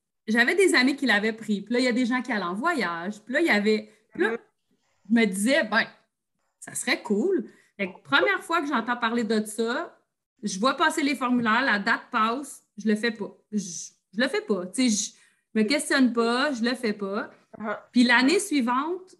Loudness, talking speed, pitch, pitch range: -24 LUFS, 210 wpm, 235 Hz, 210-275 Hz